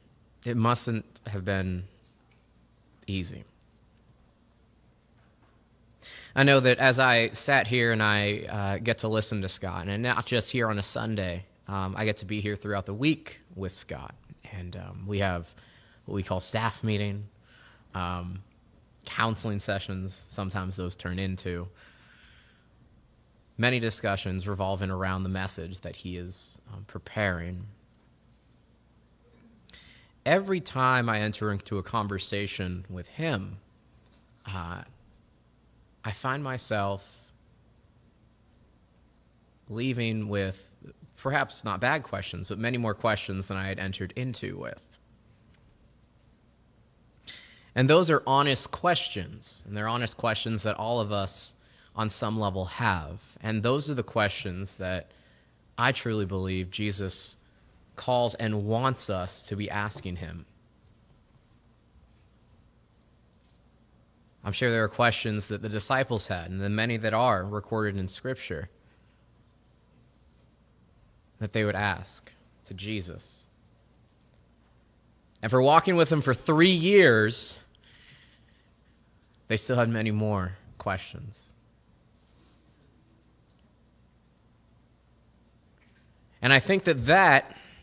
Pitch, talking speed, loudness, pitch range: 105 Hz, 115 wpm, -27 LUFS, 95-115 Hz